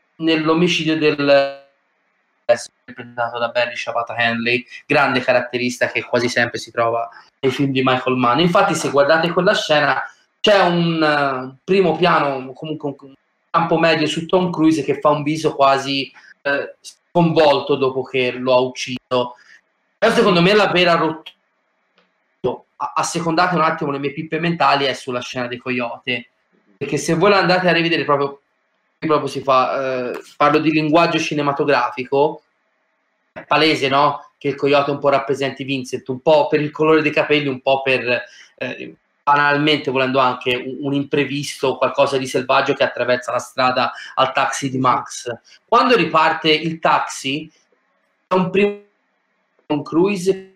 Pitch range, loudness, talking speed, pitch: 130-160 Hz, -17 LUFS, 155 wpm, 145 Hz